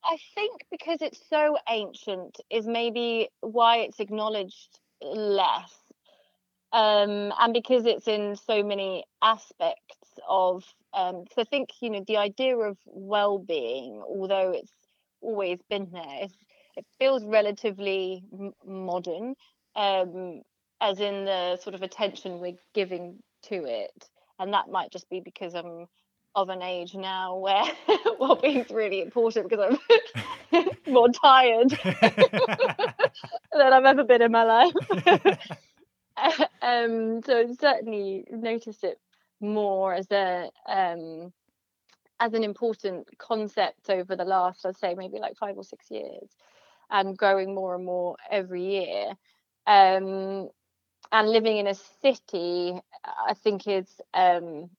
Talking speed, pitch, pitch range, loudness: 135 wpm, 210 Hz, 190-240 Hz, -25 LUFS